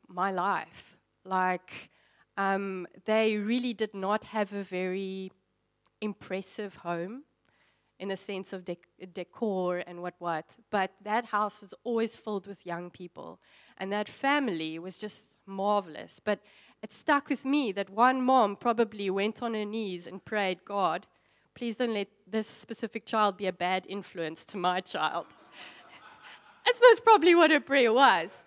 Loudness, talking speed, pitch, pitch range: -29 LUFS, 155 wpm, 200 Hz, 185-225 Hz